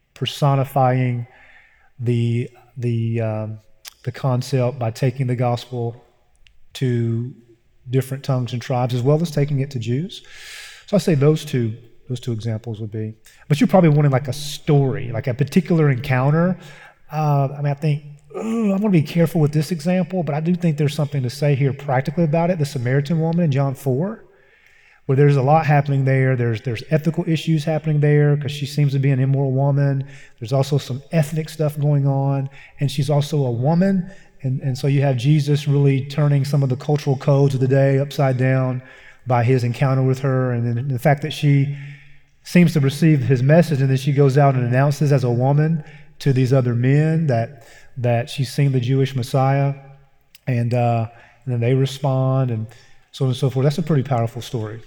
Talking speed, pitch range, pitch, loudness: 195 wpm, 125-150 Hz, 140 Hz, -19 LUFS